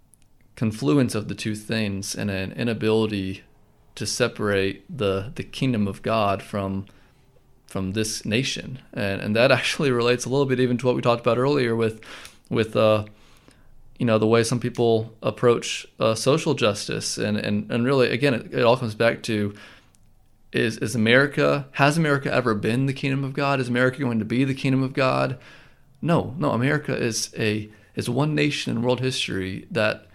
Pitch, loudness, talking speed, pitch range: 120 Hz, -23 LUFS, 180 wpm, 105-130 Hz